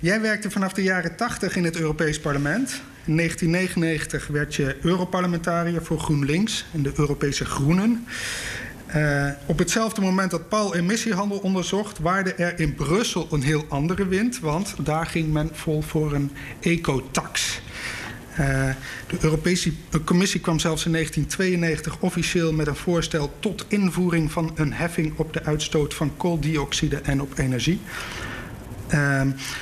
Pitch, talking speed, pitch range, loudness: 165 Hz, 145 wpm, 145-180 Hz, -24 LUFS